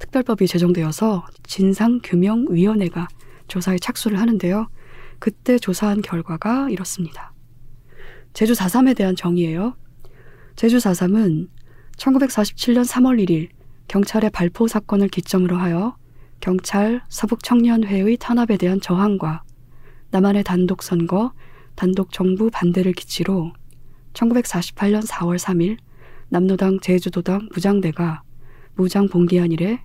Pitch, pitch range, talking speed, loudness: 185 Hz, 170-215 Hz, 245 characters per minute, -19 LUFS